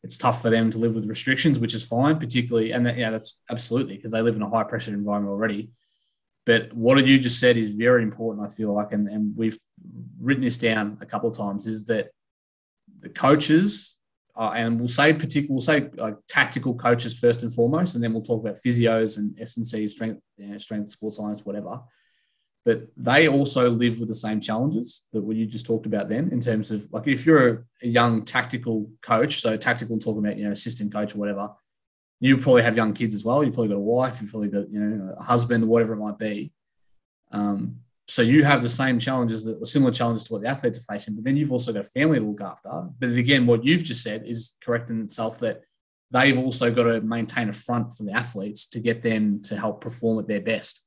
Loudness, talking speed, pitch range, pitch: -23 LUFS, 230 wpm, 105-125 Hz, 115 Hz